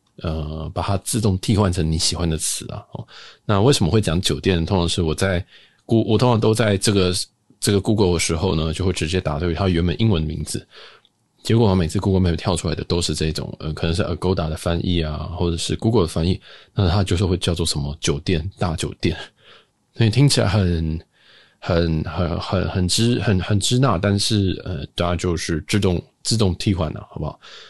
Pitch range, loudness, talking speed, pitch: 85-105 Hz, -20 LUFS, 330 characters per minute, 90 Hz